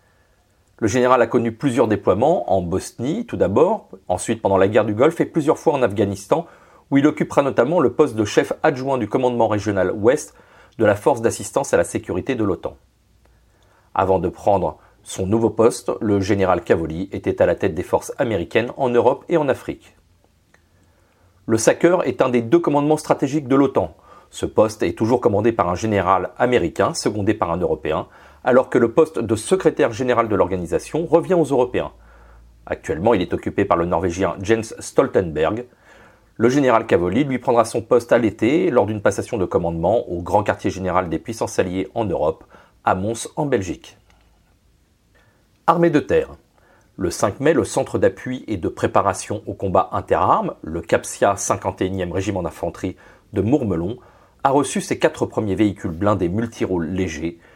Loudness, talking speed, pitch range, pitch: -19 LUFS, 175 wpm, 90-125 Hz, 105 Hz